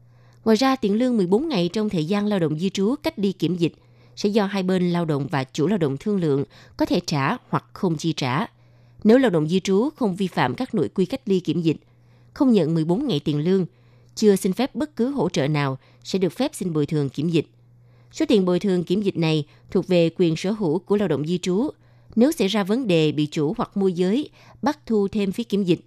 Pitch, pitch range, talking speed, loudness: 180 Hz, 150-210 Hz, 245 wpm, -22 LUFS